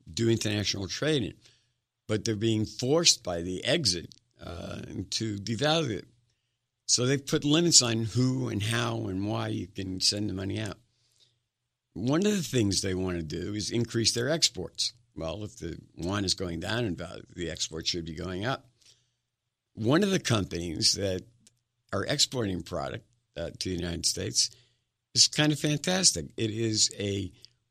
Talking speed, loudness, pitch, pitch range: 165 wpm, -28 LUFS, 115 Hz, 100-120 Hz